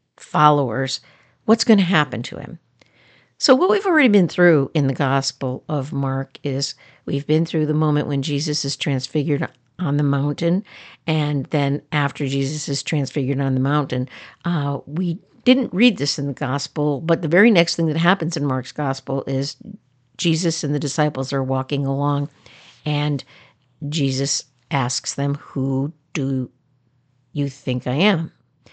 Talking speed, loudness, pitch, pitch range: 160 wpm, -20 LUFS, 145 Hz, 135-155 Hz